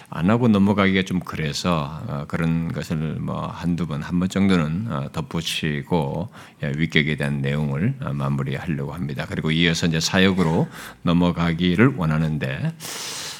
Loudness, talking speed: -22 LUFS, 300 characters per minute